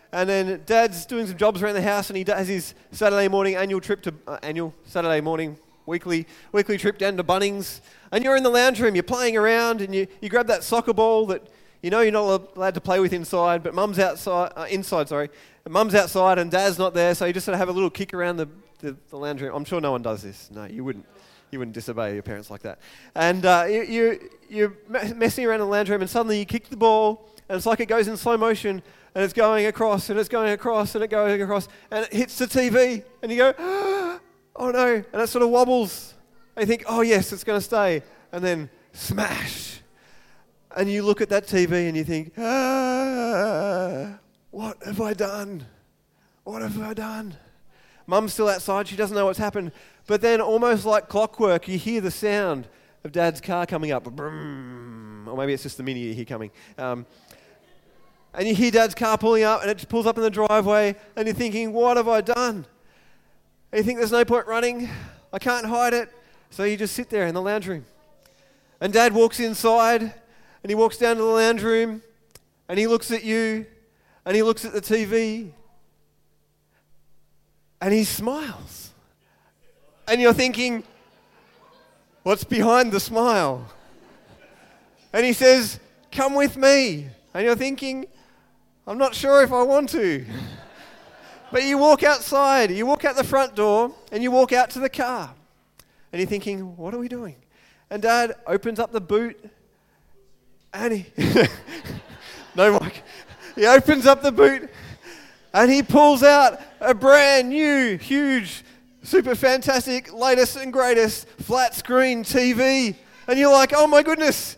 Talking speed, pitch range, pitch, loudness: 190 wpm, 185-240 Hz, 215 Hz, -21 LUFS